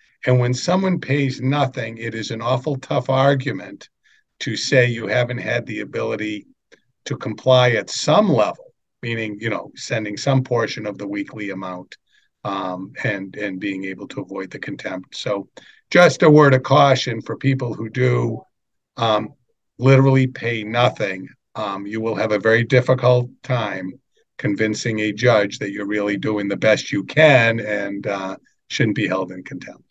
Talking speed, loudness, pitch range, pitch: 165 wpm, -19 LUFS, 105-135 Hz, 120 Hz